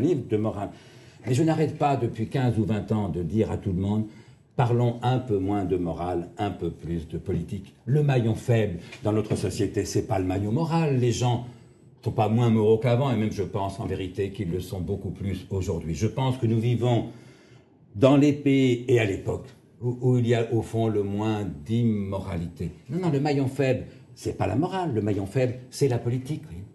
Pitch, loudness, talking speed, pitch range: 110 Hz, -26 LUFS, 220 wpm, 100-125 Hz